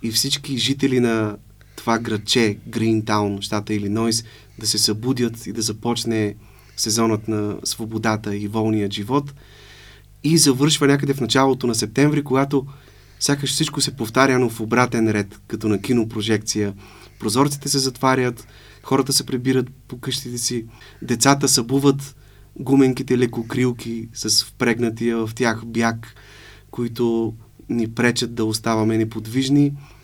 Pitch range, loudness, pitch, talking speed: 110-130 Hz, -20 LUFS, 115 Hz, 130 wpm